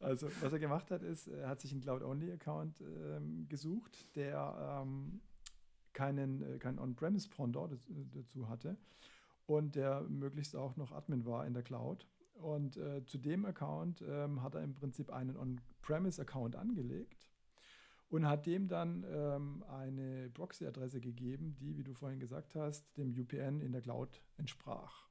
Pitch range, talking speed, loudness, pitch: 130-150 Hz, 155 wpm, -43 LUFS, 140 Hz